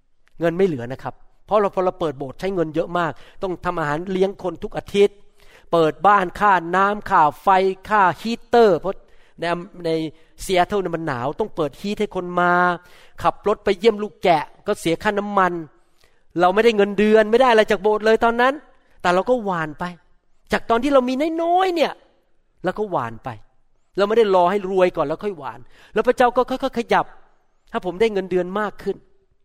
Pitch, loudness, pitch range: 190 Hz, -20 LUFS, 170-215 Hz